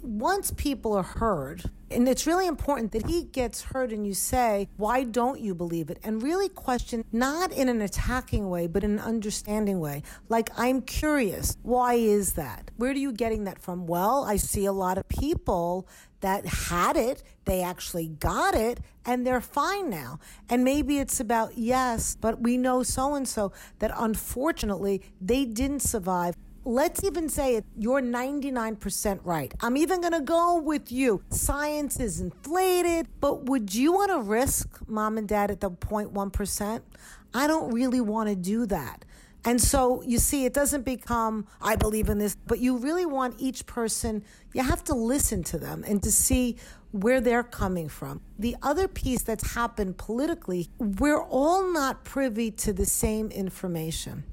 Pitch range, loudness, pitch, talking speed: 205-270 Hz, -27 LUFS, 235 Hz, 175 wpm